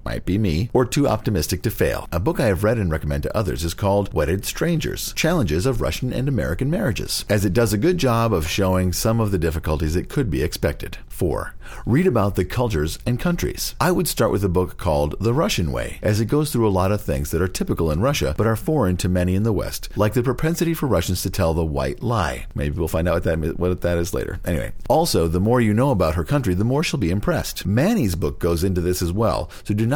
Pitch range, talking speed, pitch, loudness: 85-115 Hz, 250 wpm, 100 Hz, -21 LUFS